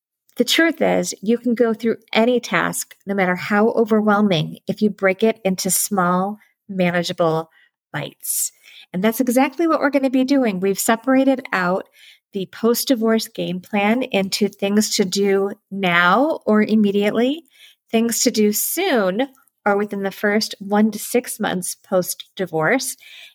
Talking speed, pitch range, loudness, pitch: 150 wpm, 195-245 Hz, -19 LUFS, 215 Hz